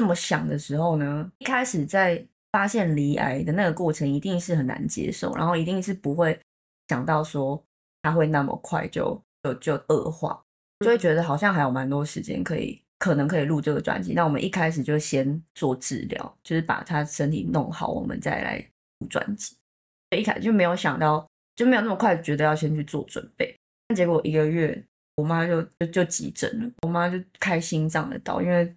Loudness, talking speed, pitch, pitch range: -25 LUFS, 295 characters per minute, 165 Hz, 150-180 Hz